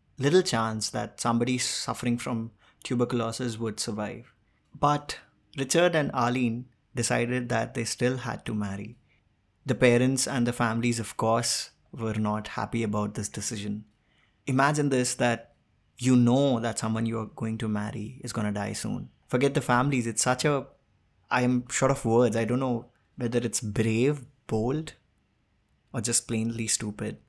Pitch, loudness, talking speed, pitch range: 120 Hz, -27 LUFS, 160 wpm, 110-125 Hz